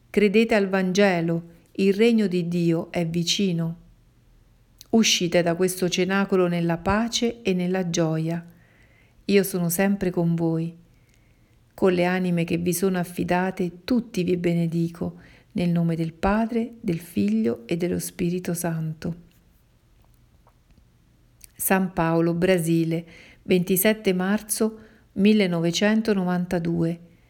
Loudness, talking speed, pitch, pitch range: -23 LUFS, 110 wpm, 175 Hz, 165-195 Hz